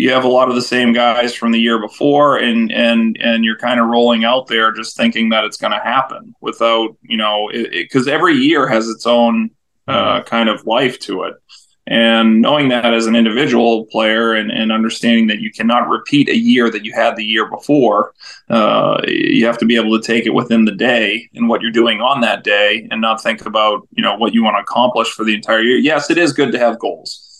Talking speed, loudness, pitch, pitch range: 230 wpm, -13 LUFS, 115 Hz, 110-120 Hz